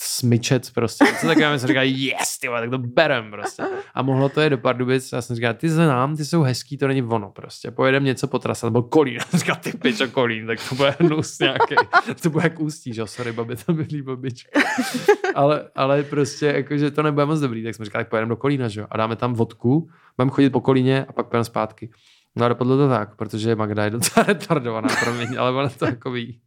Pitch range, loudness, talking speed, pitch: 120-150 Hz, -21 LUFS, 225 wpm, 130 Hz